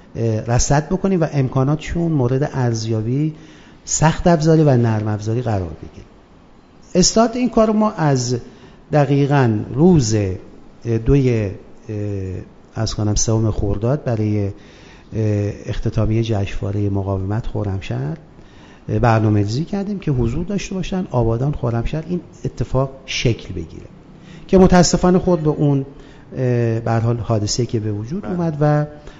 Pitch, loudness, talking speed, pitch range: 120 Hz, -18 LUFS, 110 wpm, 110-155 Hz